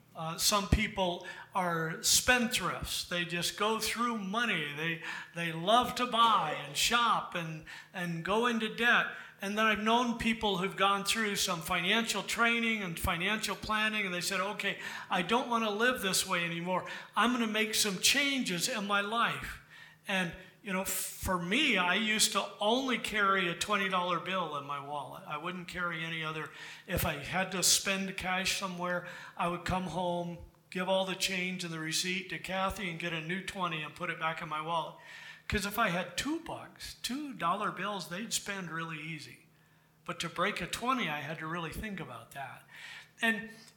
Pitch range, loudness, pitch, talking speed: 175-215 Hz, -31 LUFS, 190 Hz, 185 wpm